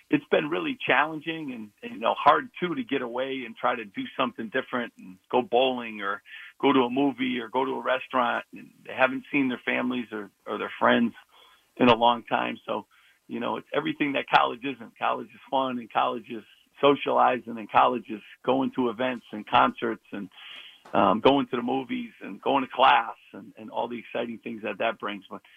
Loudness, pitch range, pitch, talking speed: -26 LUFS, 120-140 Hz, 130 Hz, 210 wpm